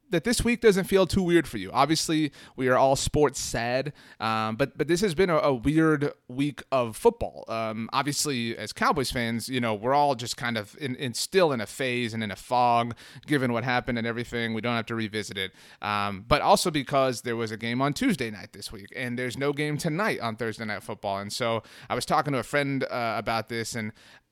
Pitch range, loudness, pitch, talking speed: 115-145 Hz, -26 LUFS, 125 Hz, 230 wpm